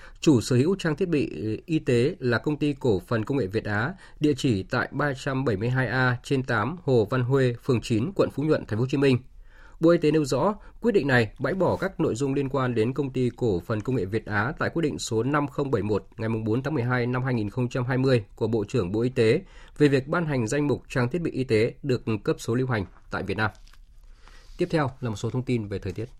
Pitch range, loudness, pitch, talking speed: 115-145 Hz, -25 LUFS, 125 Hz, 245 wpm